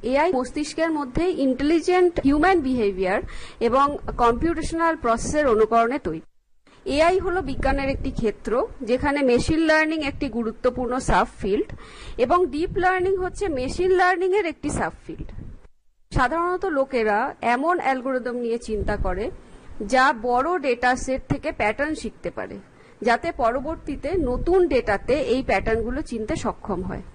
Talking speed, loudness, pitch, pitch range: 130 wpm, -23 LUFS, 275 Hz, 245-335 Hz